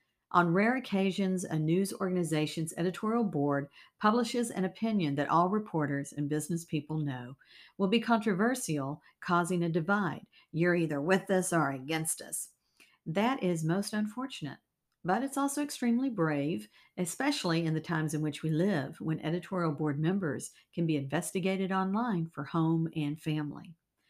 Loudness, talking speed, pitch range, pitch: -32 LUFS, 150 wpm, 155-195 Hz, 175 Hz